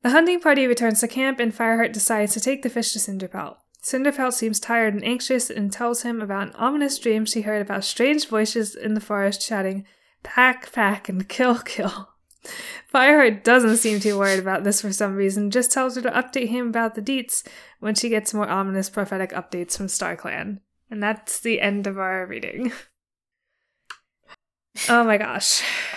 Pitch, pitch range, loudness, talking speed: 225 Hz, 205-250 Hz, -21 LUFS, 185 wpm